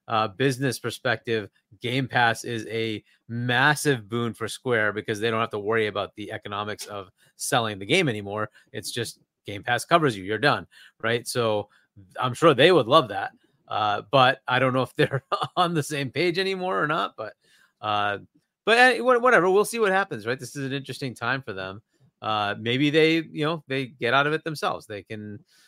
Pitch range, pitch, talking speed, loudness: 110-150 Hz, 120 Hz, 195 wpm, -24 LUFS